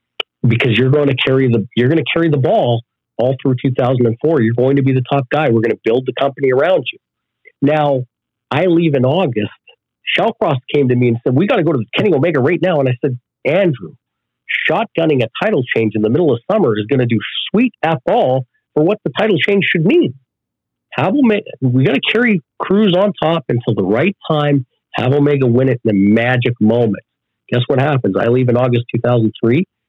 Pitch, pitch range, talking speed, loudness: 130 Hz, 120-150 Hz, 215 wpm, -14 LUFS